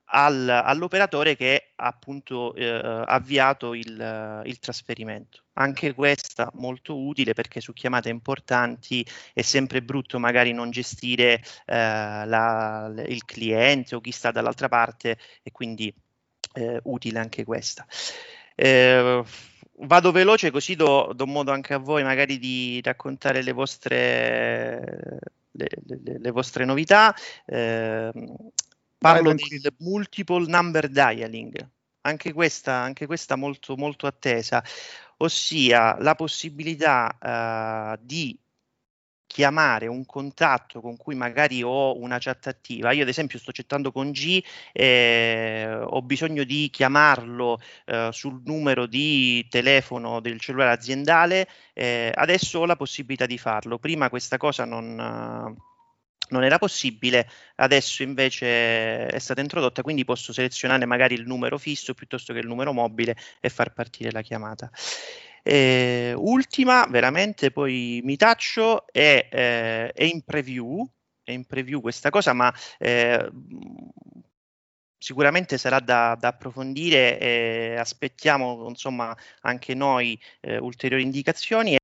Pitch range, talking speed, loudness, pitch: 120-145 Hz, 130 wpm, -22 LUFS, 130 Hz